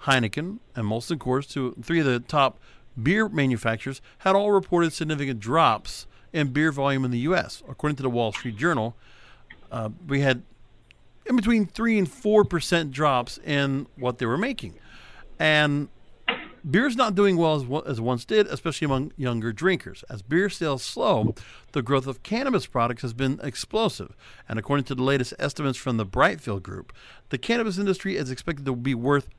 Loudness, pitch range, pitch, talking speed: -25 LUFS, 125-170 Hz, 140 Hz, 180 wpm